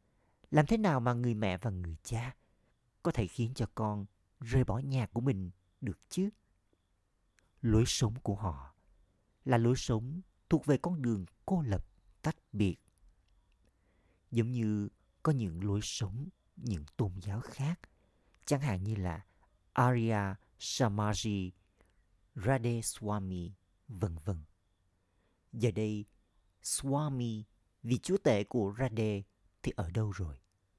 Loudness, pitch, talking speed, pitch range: -35 LUFS, 105 Hz, 135 wpm, 95-120 Hz